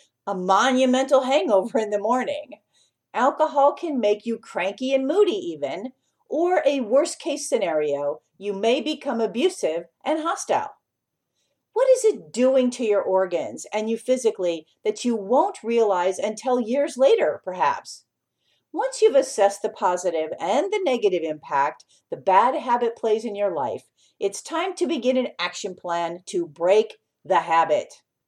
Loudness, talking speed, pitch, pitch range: -23 LUFS, 150 wpm, 240 Hz, 195-295 Hz